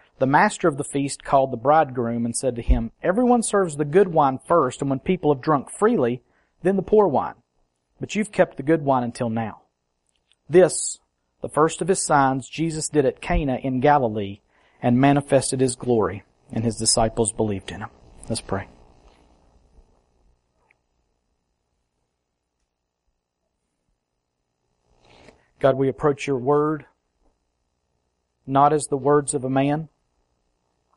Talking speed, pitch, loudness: 140 wpm, 115 Hz, -21 LUFS